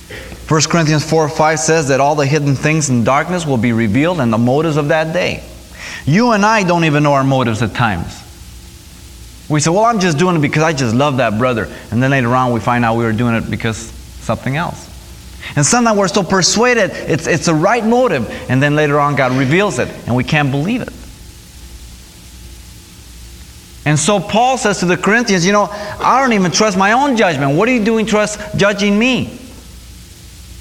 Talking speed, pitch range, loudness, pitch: 200 wpm, 120-195 Hz, -13 LUFS, 150 Hz